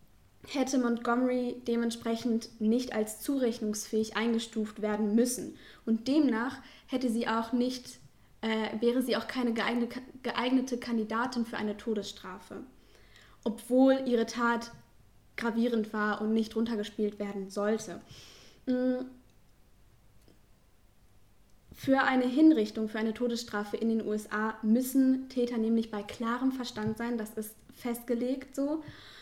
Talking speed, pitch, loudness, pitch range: 115 wpm, 230 Hz, -31 LUFS, 215-250 Hz